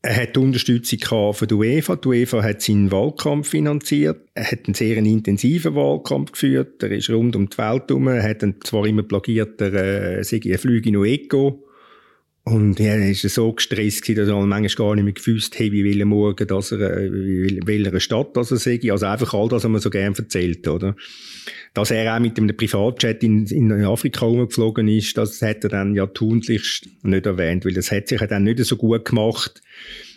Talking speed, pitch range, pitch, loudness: 205 wpm, 100-115 Hz, 110 Hz, -19 LUFS